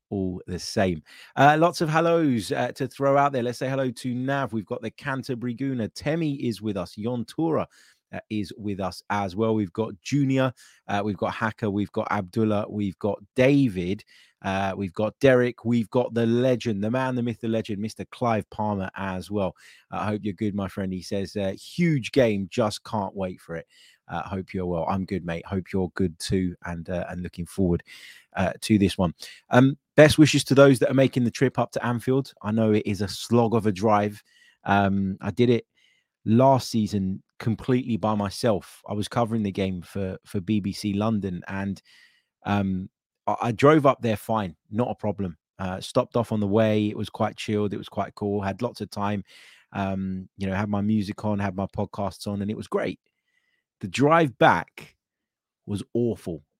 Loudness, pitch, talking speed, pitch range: -25 LUFS, 105 Hz, 200 wpm, 95-120 Hz